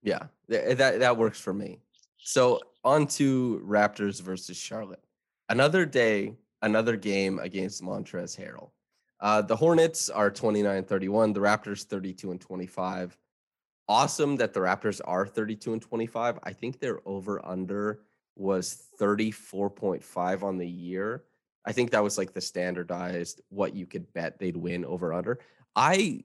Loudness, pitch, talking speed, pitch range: -28 LUFS, 100 Hz, 145 wpm, 95-110 Hz